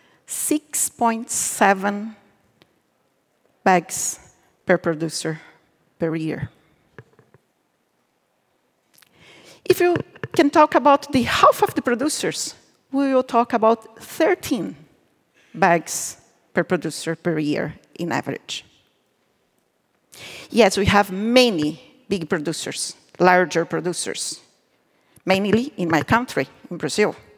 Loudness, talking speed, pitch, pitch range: -21 LUFS, 90 wpm, 205 Hz, 165-260 Hz